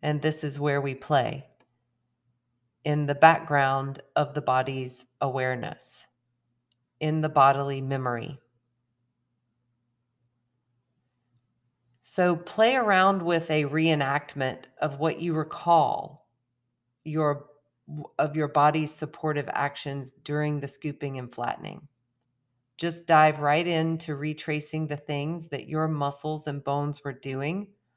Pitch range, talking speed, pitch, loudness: 120-155 Hz, 110 wpm, 140 Hz, -26 LUFS